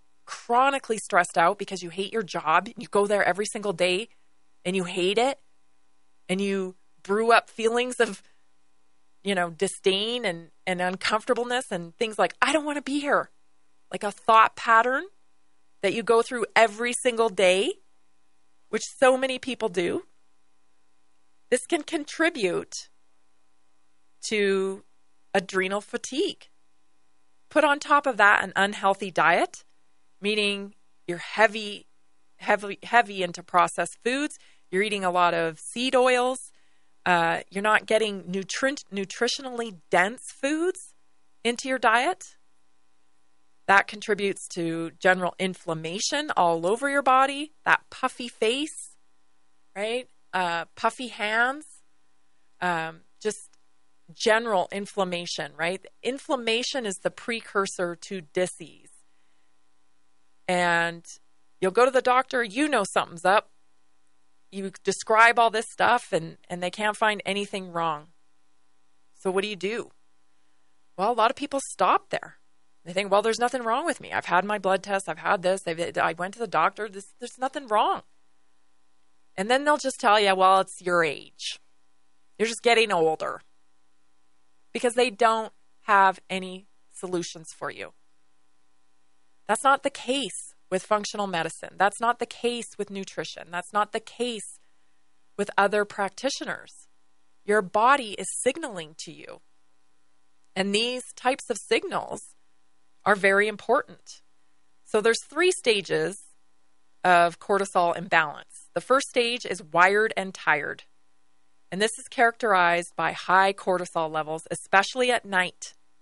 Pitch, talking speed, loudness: 185 Hz, 135 wpm, -25 LUFS